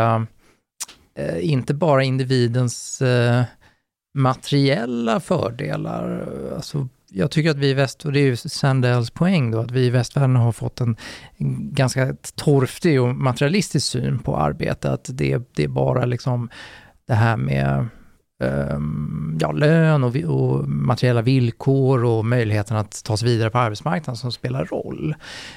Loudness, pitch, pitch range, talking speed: -21 LUFS, 125 Hz, 110-140 Hz, 145 wpm